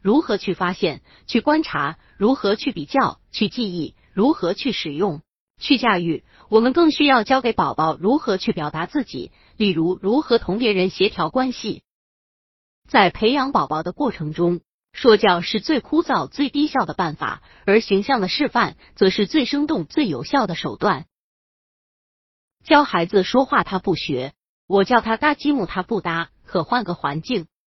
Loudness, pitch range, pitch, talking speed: -20 LUFS, 180-265 Hz, 215 Hz, 240 characters per minute